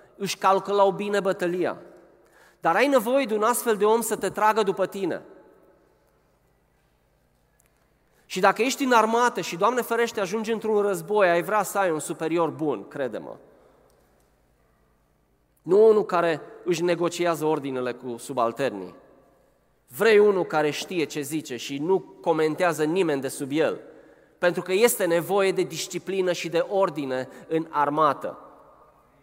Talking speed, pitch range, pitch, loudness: 145 wpm, 155-215 Hz, 185 Hz, -24 LUFS